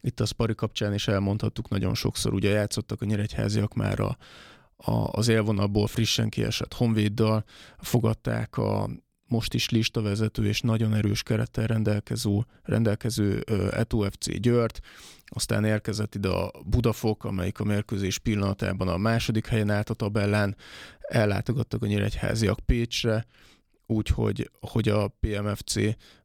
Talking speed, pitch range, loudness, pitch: 130 wpm, 105-115 Hz, -27 LUFS, 110 Hz